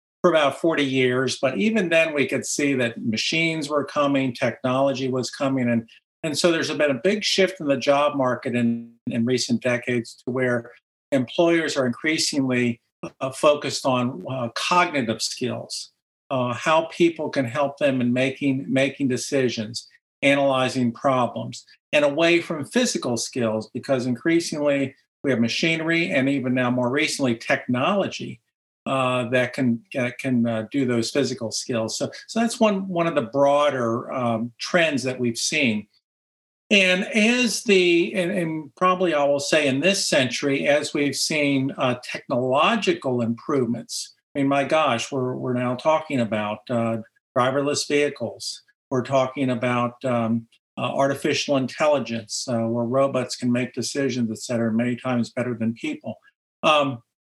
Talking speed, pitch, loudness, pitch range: 150 wpm, 135 Hz, -22 LUFS, 120-150 Hz